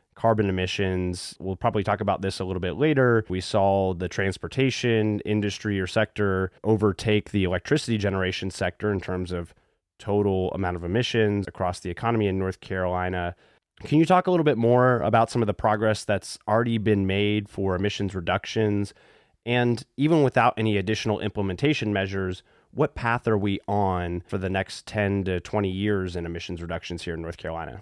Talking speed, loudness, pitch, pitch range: 175 wpm, -25 LUFS, 100 Hz, 95-110 Hz